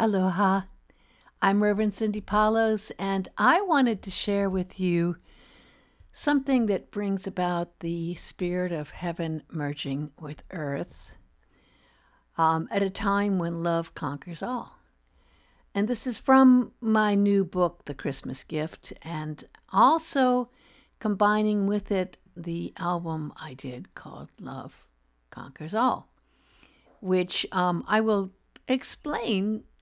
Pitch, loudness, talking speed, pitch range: 190 Hz, -27 LUFS, 120 wpm, 170-215 Hz